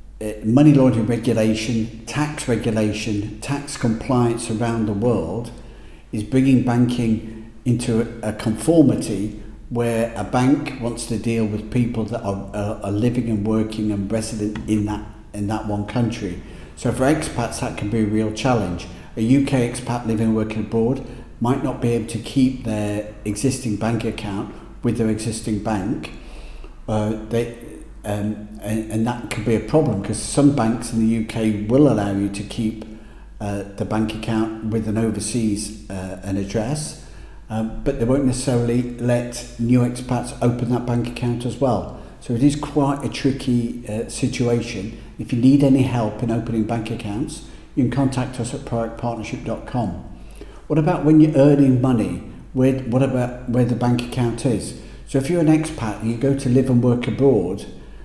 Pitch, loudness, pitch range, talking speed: 115 Hz, -21 LUFS, 110-125 Hz, 170 wpm